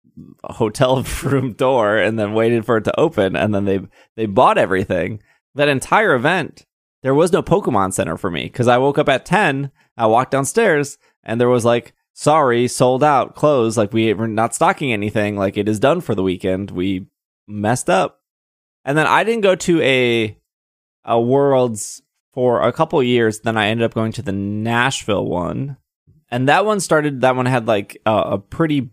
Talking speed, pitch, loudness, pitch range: 190 wpm, 115 Hz, -17 LUFS, 105-135 Hz